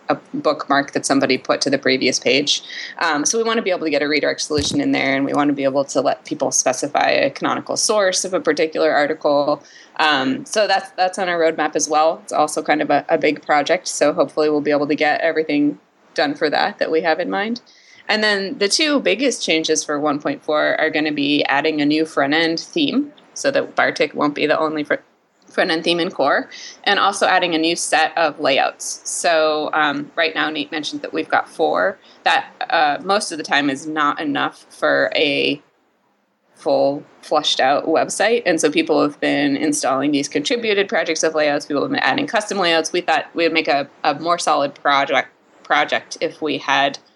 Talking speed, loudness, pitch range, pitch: 210 wpm, -18 LUFS, 145-195 Hz, 160 Hz